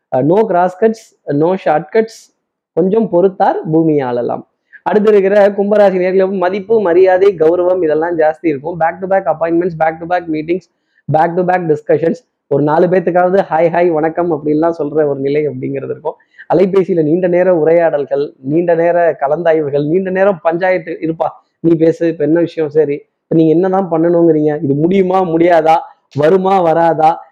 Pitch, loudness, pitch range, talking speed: 170 Hz, -13 LUFS, 155-185 Hz, 140 wpm